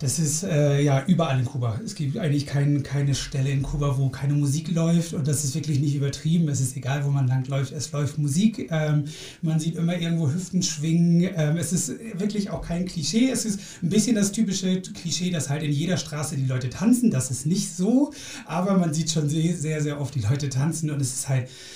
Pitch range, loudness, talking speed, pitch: 140-175 Hz, -24 LUFS, 225 wpm, 155 Hz